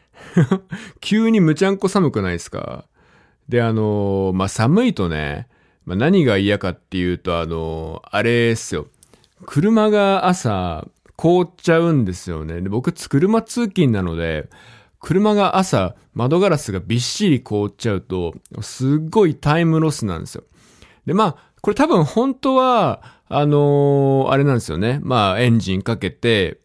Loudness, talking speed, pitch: -18 LUFS, 275 characters per minute, 135 Hz